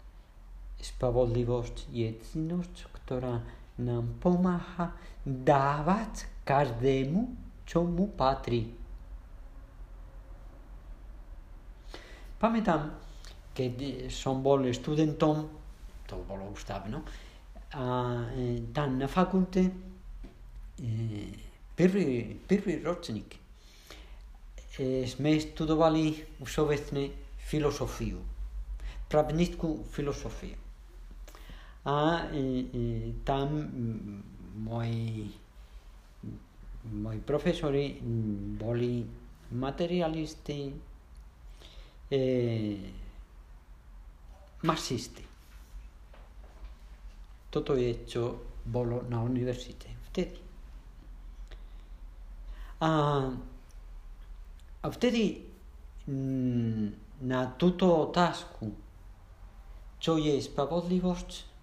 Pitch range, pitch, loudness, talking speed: 95-150 Hz, 120 Hz, -31 LUFS, 60 wpm